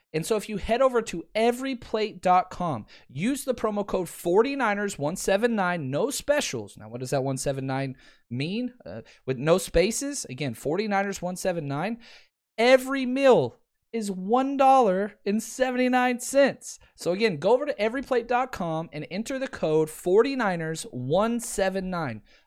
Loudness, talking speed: -26 LUFS, 110 wpm